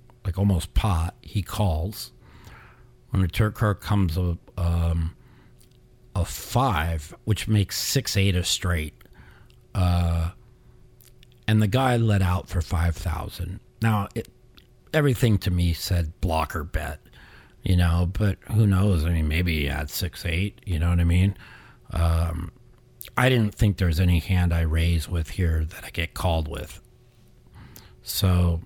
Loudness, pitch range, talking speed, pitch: -25 LUFS, 85-115 Hz, 145 wpm, 95 Hz